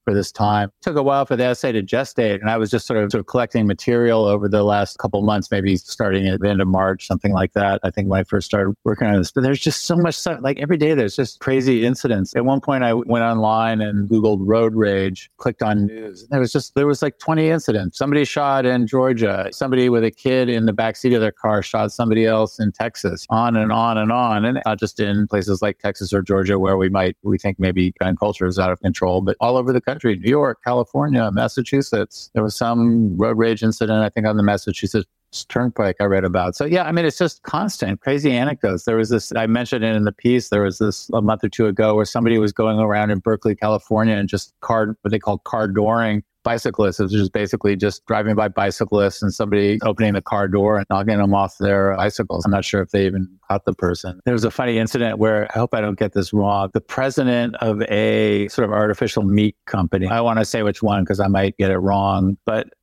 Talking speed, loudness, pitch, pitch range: 245 wpm, -19 LUFS, 110 Hz, 100-120 Hz